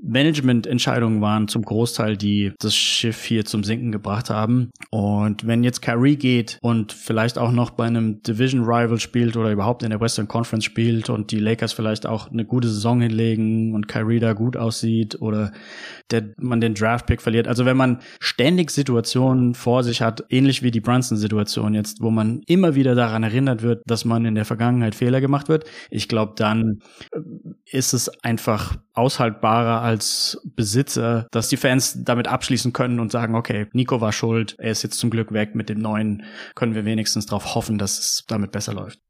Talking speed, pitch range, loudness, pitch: 185 wpm, 110-125 Hz, -21 LUFS, 115 Hz